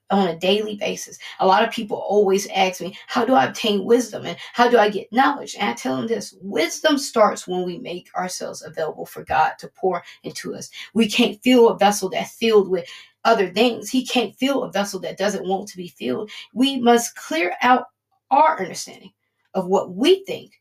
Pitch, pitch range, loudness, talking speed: 215 Hz, 195-245 Hz, -20 LUFS, 205 wpm